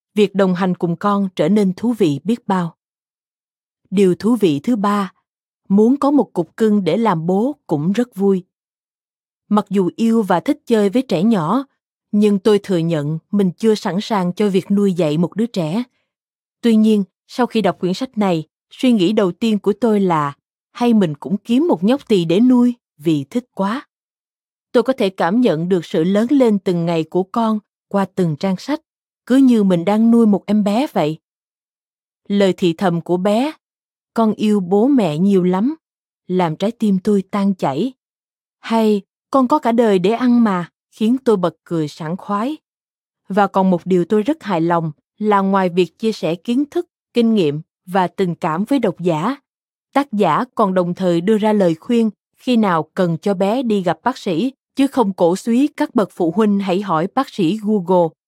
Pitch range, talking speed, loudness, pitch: 180-230 Hz, 195 wpm, -17 LUFS, 205 Hz